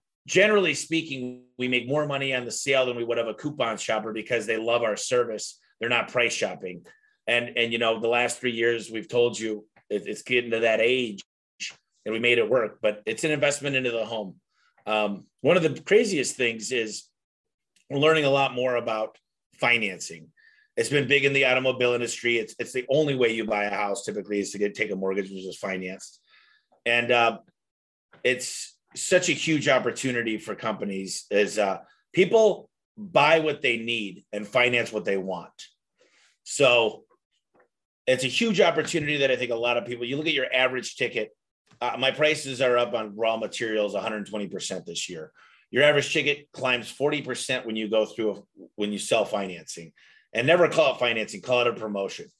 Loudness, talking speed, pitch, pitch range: -25 LUFS, 190 wpm, 120 Hz, 110-140 Hz